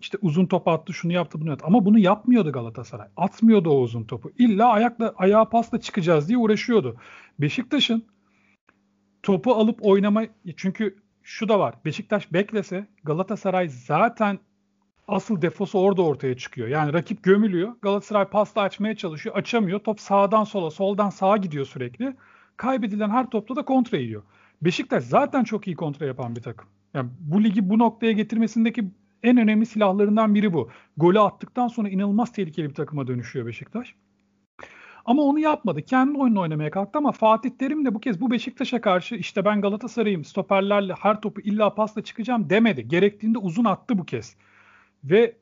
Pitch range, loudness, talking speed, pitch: 165-225 Hz, -22 LUFS, 160 wpm, 200 Hz